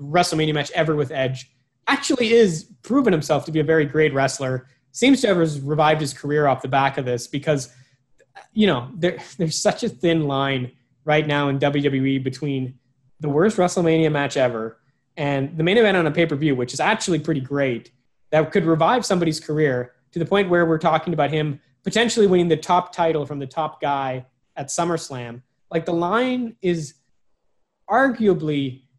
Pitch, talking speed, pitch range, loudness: 150 Hz, 180 wpm, 135-170 Hz, -21 LUFS